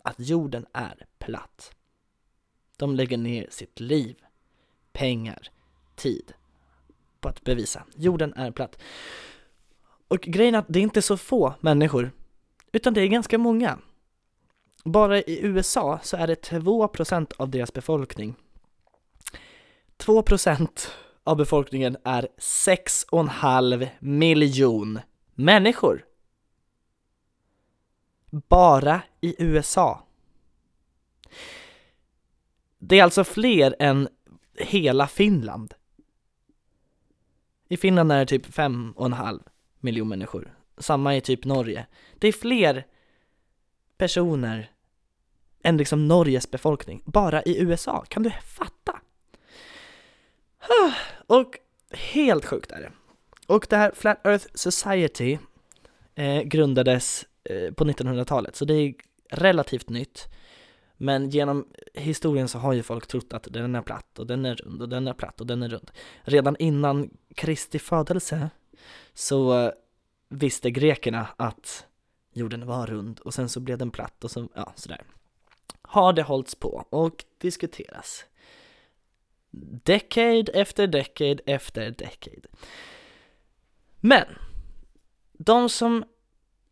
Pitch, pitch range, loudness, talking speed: 140 Hz, 120-175 Hz, -23 LUFS, 115 wpm